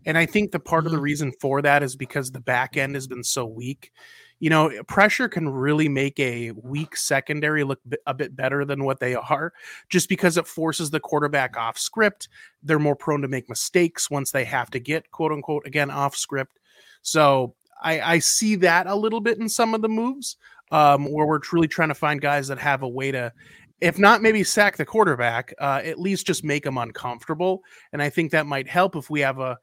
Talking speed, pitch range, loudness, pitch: 220 wpm, 135-170 Hz, -22 LUFS, 150 Hz